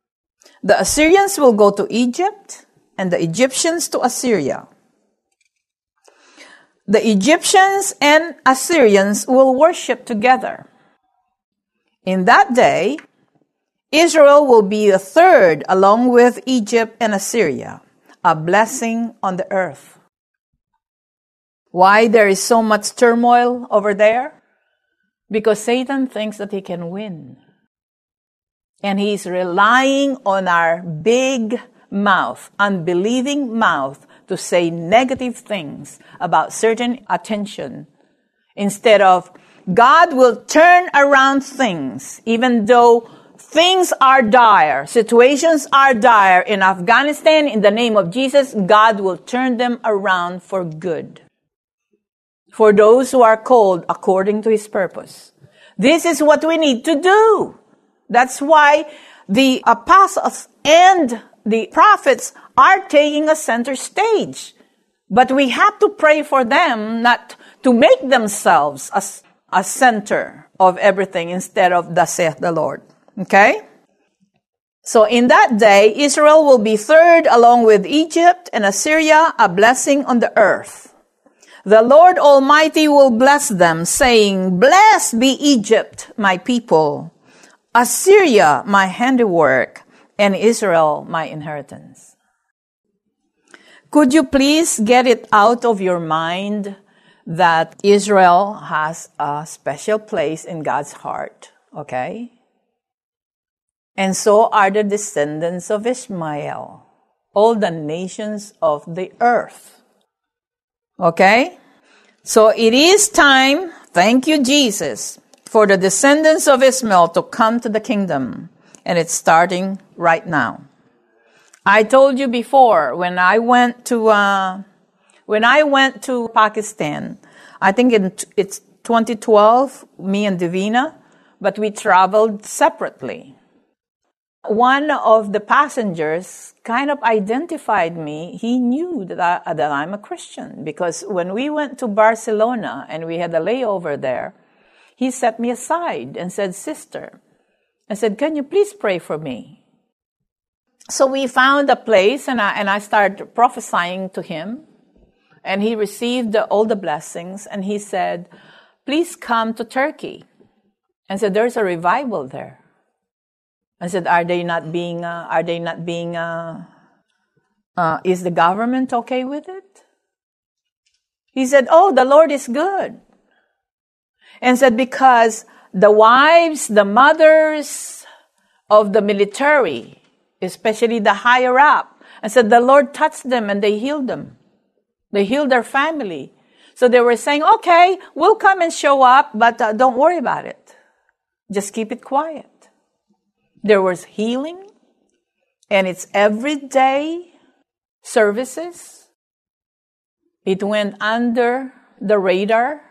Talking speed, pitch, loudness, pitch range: 125 wpm, 230 Hz, -14 LUFS, 195-275 Hz